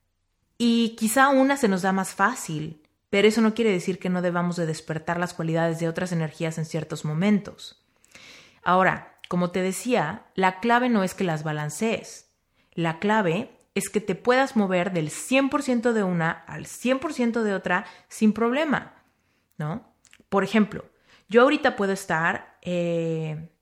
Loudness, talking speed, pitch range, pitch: -24 LUFS, 160 wpm, 165-230 Hz, 190 Hz